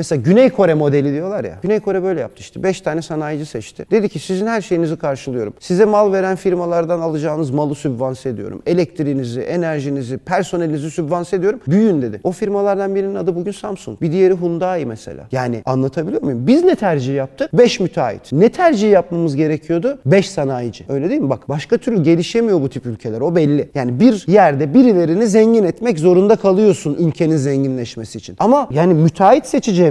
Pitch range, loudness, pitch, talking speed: 145-195 Hz, -16 LUFS, 170 Hz, 175 wpm